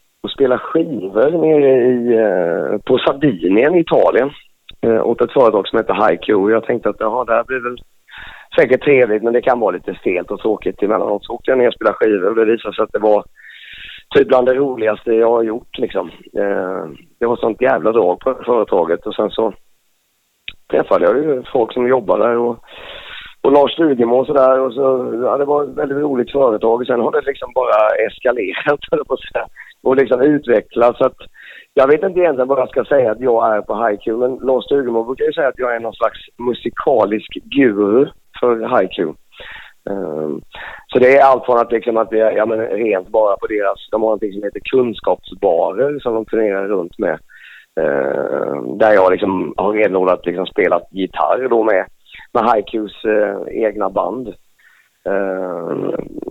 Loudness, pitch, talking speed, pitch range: -16 LUFS, 125 Hz, 185 wpm, 110-140 Hz